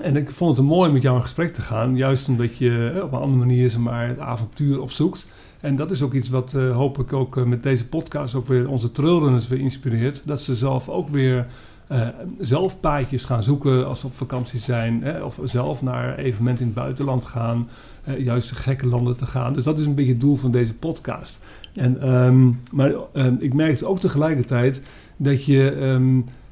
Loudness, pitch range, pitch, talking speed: -21 LUFS, 125-140 Hz, 130 Hz, 215 wpm